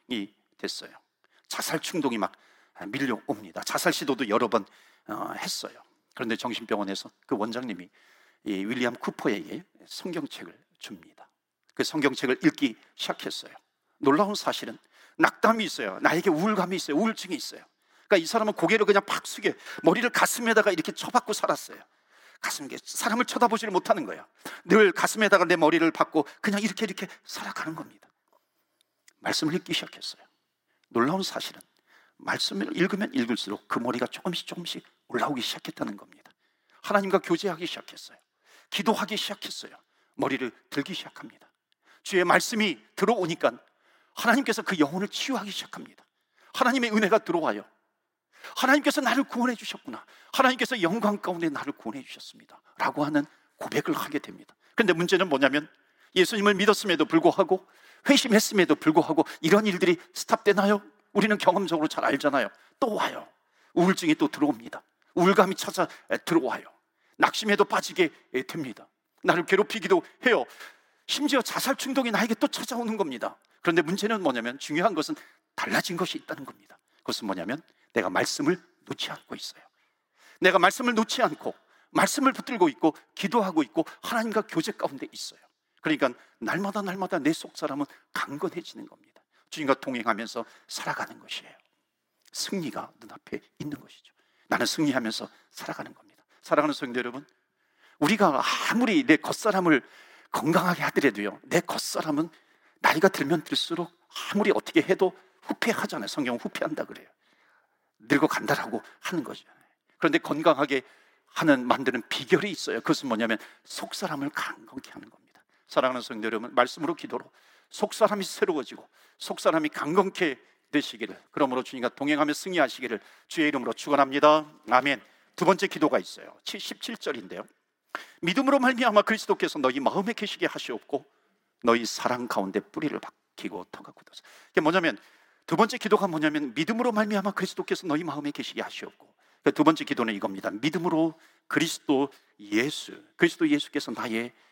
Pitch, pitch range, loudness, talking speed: 200 Hz, 165-240 Hz, -26 LUFS, 375 characters per minute